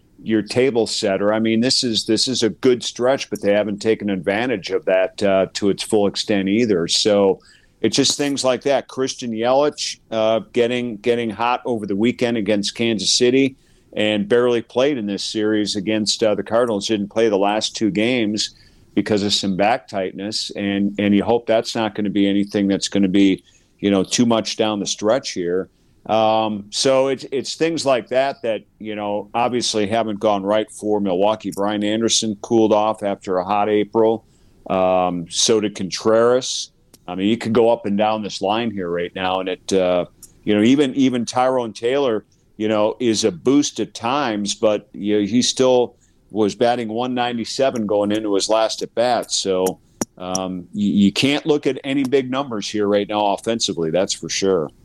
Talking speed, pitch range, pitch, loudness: 195 wpm, 100-120 Hz, 110 Hz, -19 LUFS